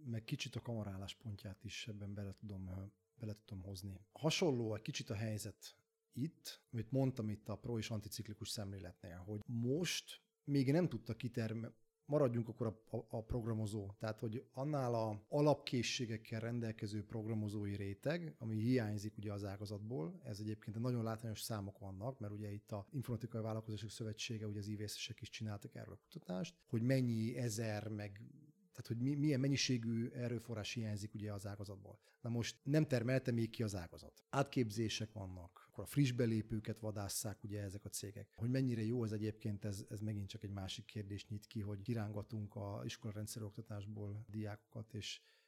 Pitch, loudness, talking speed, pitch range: 110 Hz, -43 LUFS, 165 wpm, 105-125 Hz